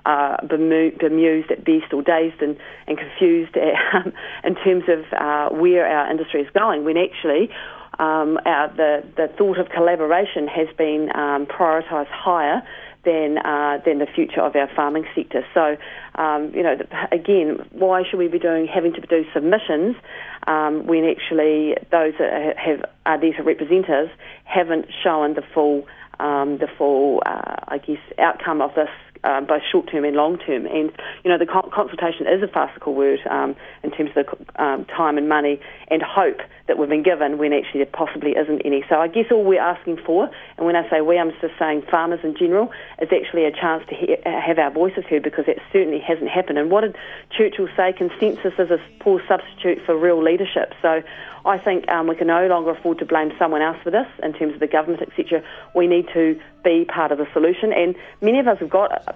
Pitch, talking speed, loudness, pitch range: 165 Hz, 195 wpm, -20 LUFS, 155-175 Hz